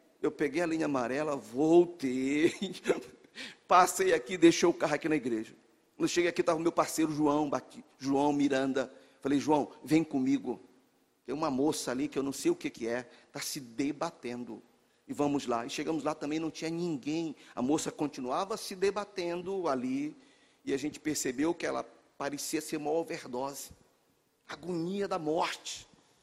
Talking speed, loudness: 165 wpm, -32 LUFS